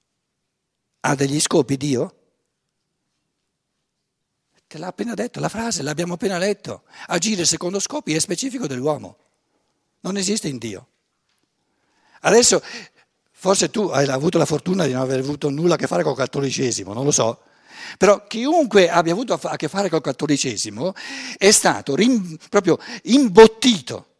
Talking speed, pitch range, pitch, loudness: 140 wpm, 140-200 Hz, 170 Hz, -19 LUFS